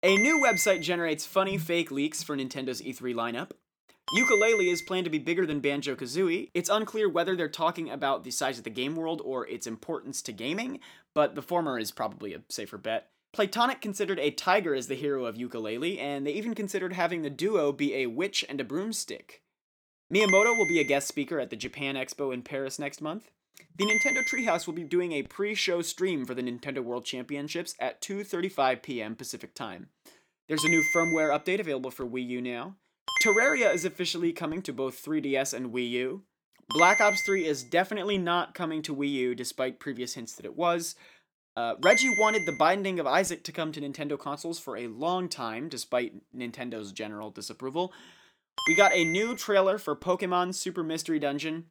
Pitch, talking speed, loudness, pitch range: 165 Hz, 190 wpm, -28 LUFS, 135-190 Hz